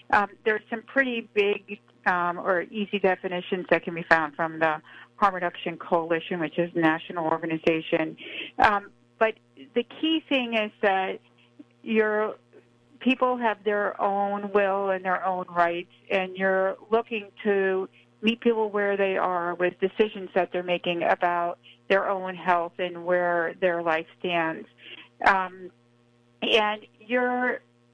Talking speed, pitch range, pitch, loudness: 140 wpm, 170-210 Hz, 185 Hz, -26 LUFS